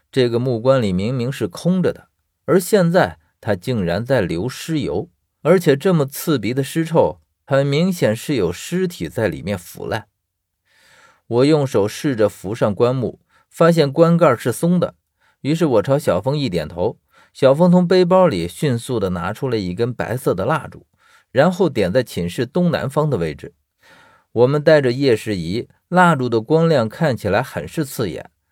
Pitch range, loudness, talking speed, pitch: 110-165 Hz, -18 LUFS, 245 characters per minute, 135 Hz